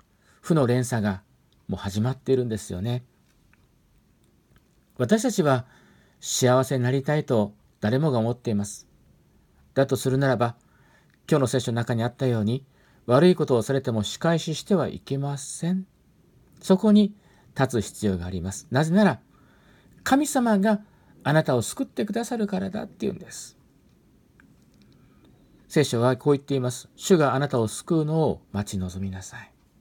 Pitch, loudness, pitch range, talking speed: 130 Hz, -24 LUFS, 115-165 Hz, 300 characters per minute